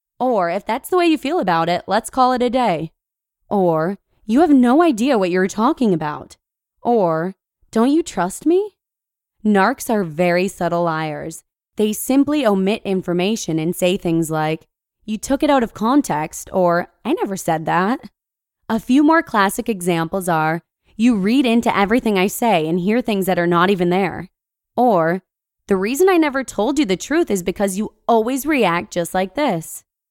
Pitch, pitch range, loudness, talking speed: 200 Hz, 175-245 Hz, -18 LUFS, 175 wpm